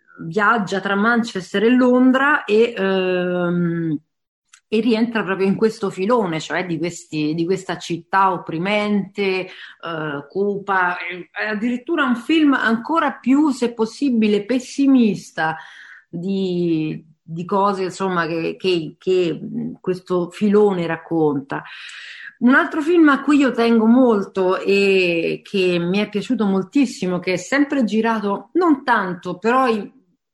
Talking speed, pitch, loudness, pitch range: 125 wpm, 200 Hz, -19 LUFS, 180-235 Hz